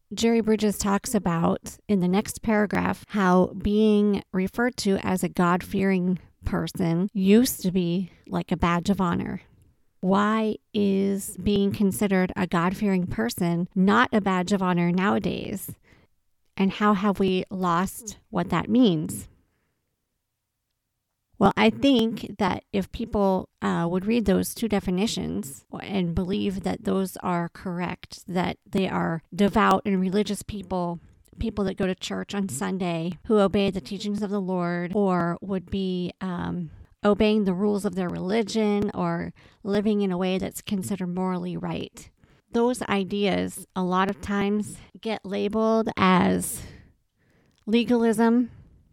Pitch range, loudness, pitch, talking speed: 180-205 Hz, -25 LUFS, 195 Hz, 140 wpm